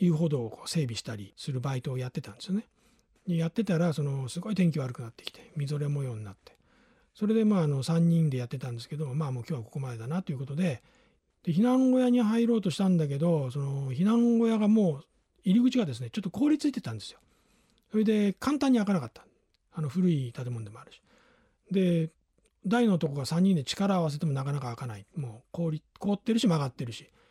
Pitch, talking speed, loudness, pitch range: 165 Hz, 400 characters per minute, -29 LUFS, 135-205 Hz